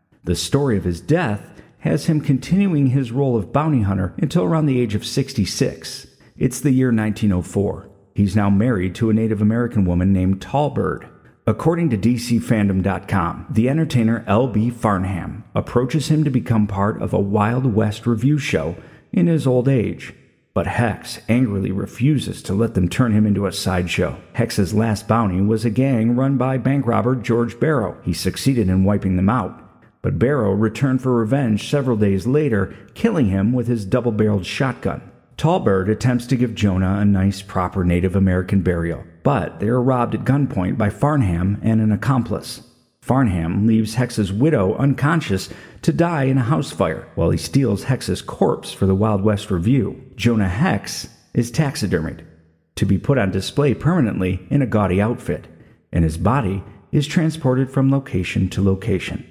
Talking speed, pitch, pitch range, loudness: 165 wpm, 110 Hz, 95-130 Hz, -19 LUFS